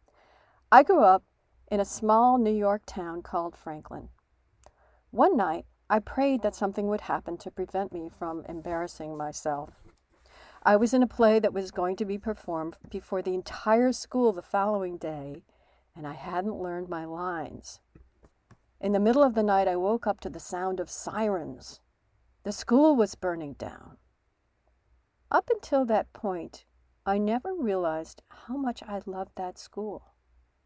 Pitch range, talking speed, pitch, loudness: 170-215 Hz, 160 wpm, 190 Hz, -27 LUFS